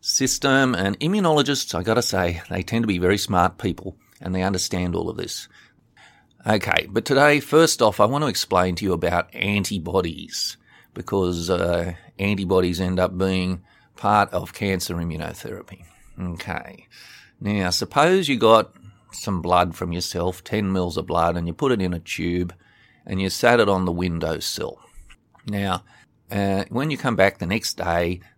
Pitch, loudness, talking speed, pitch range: 95 Hz, -22 LUFS, 165 wpm, 90-115 Hz